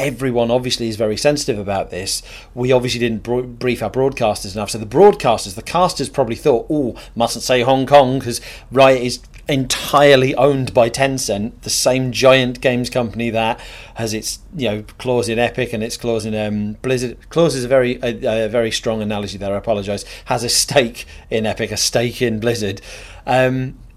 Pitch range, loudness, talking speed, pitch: 110-130 Hz, -17 LUFS, 190 wpm, 120 Hz